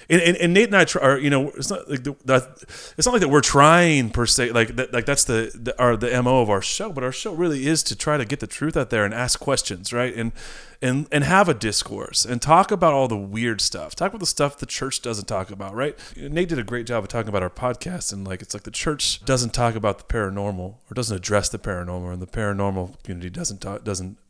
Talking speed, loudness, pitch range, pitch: 265 wpm, -21 LUFS, 105-140 Hz, 120 Hz